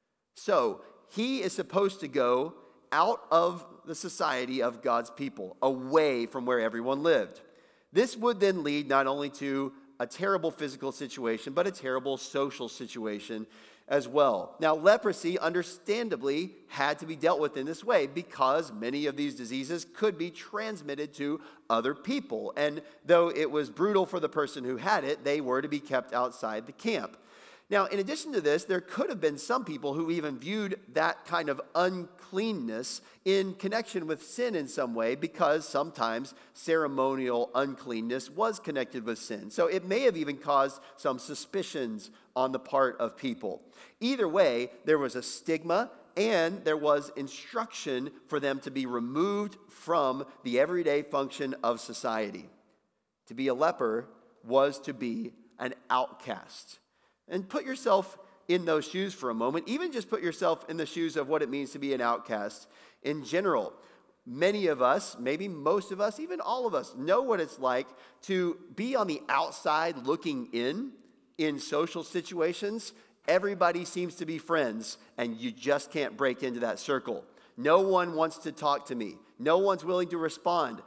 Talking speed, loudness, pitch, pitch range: 170 wpm, -30 LUFS, 155 Hz, 135-190 Hz